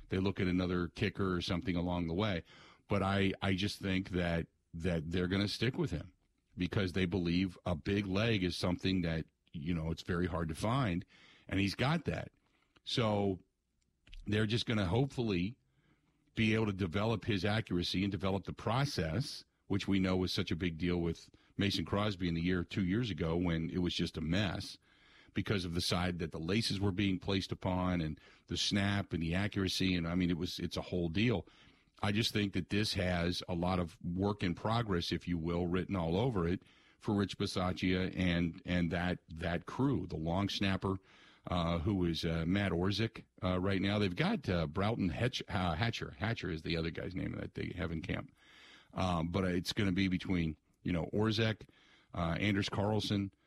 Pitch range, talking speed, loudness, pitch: 90-100 Hz, 200 wpm, -35 LUFS, 95 Hz